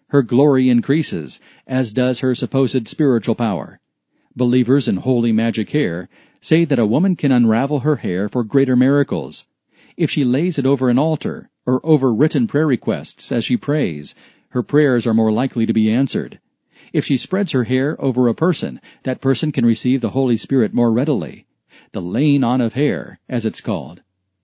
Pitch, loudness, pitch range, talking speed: 130 Hz, -18 LUFS, 120-145 Hz, 180 wpm